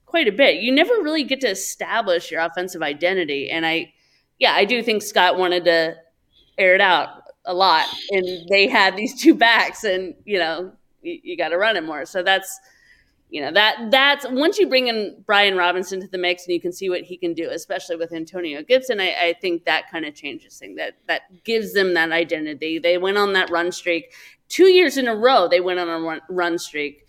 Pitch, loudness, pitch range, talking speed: 185 Hz, -19 LUFS, 170-230 Hz, 225 wpm